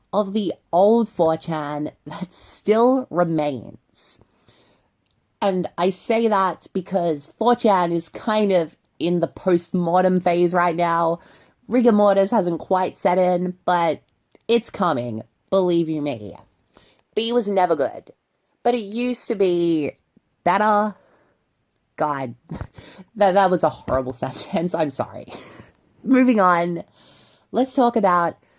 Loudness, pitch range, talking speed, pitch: -21 LUFS, 160-205 Hz, 125 wpm, 180 Hz